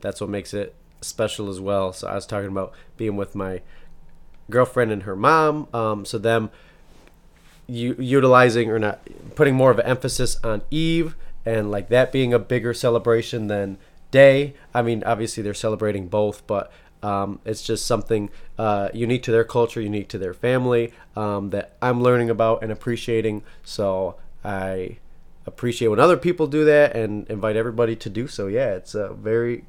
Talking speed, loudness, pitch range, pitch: 175 wpm, -21 LUFS, 105-125 Hz, 115 Hz